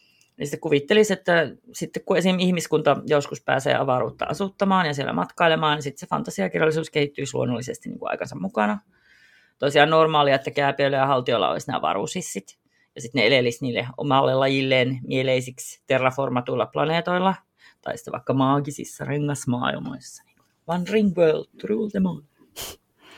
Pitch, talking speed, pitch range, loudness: 150 Hz, 140 wpm, 135-175 Hz, -23 LUFS